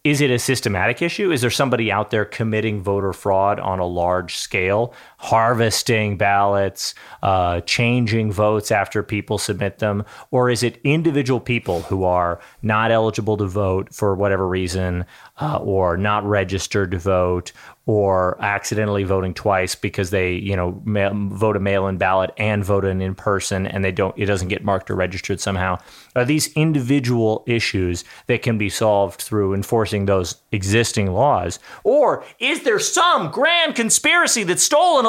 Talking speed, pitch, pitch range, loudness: 160 wpm, 105 Hz, 95-115 Hz, -19 LUFS